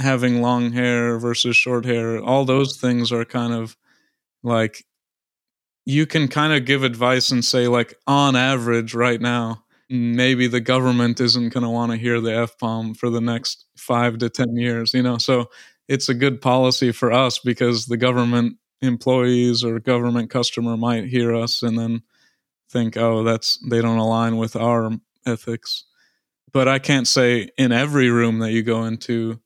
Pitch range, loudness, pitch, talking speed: 115-125 Hz, -19 LUFS, 120 Hz, 175 wpm